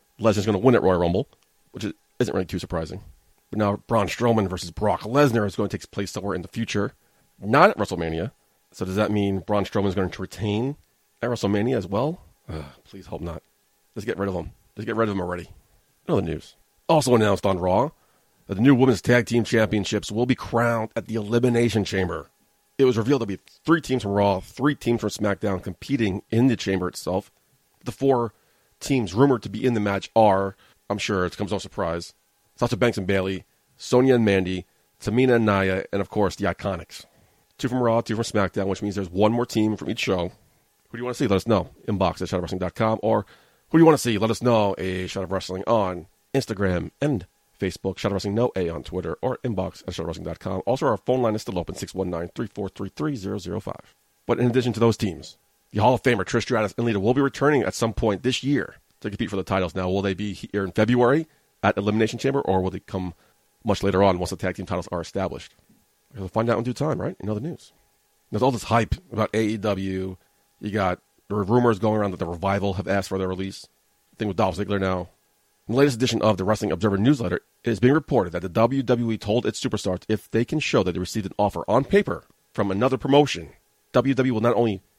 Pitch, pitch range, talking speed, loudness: 105 Hz, 95-120 Hz, 230 wpm, -24 LUFS